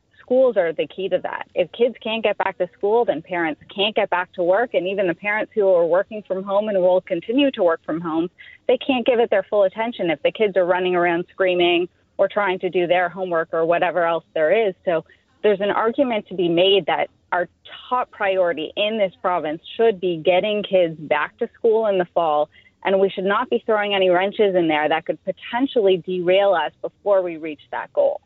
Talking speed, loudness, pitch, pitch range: 225 wpm, -20 LUFS, 190 Hz, 175-215 Hz